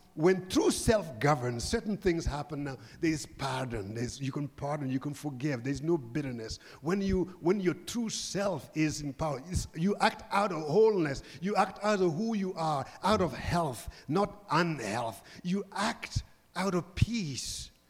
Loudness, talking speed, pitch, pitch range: -32 LUFS, 175 wpm, 160 Hz, 135-190 Hz